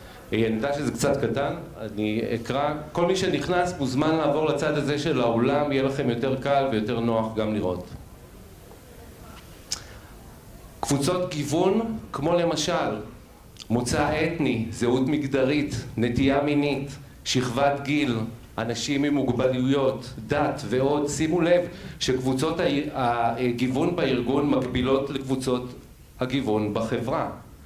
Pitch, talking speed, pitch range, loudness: 135 Hz, 110 wpm, 115-145 Hz, -25 LUFS